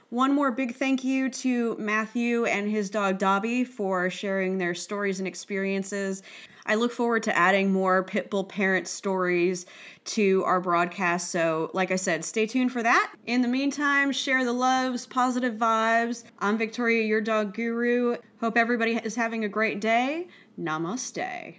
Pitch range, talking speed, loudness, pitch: 195-245 Hz, 160 wpm, -26 LUFS, 220 Hz